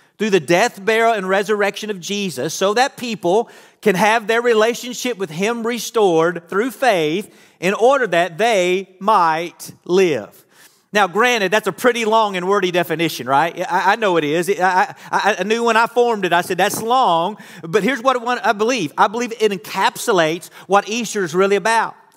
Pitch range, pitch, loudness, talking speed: 185-230 Hz, 205 Hz, -17 LUFS, 175 wpm